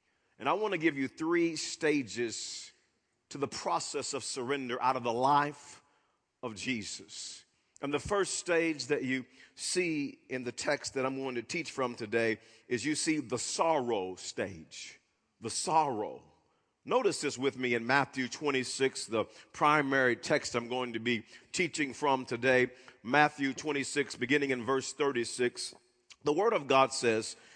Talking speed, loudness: 155 wpm, -32 LUFS